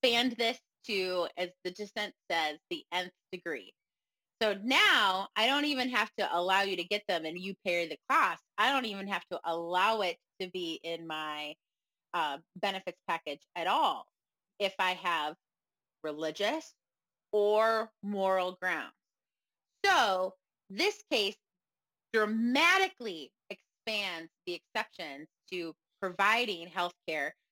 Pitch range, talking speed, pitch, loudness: 175-220 Hz, 135 wpm, 190 Hz, -31 LUFS